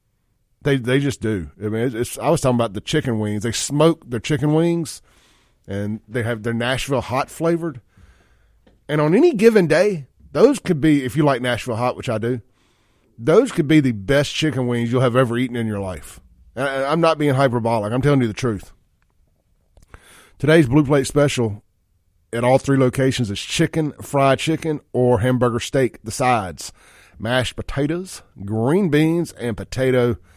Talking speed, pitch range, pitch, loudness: 180 wpm, 110-145 Hz, 125 Hz, -19 LUFS